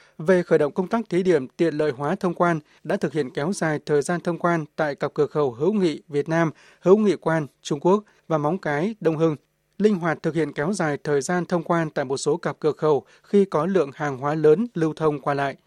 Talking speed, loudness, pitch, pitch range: 250 wpm, -23 LUFS, 160 Hz, 150-180 Hz